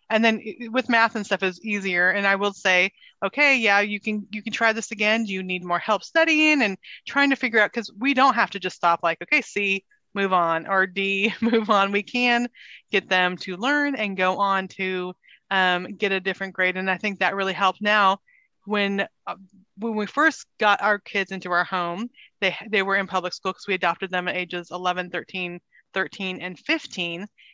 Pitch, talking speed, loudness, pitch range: 200 Hz, 215 wpm, -22 LUFS, 185-225 Hz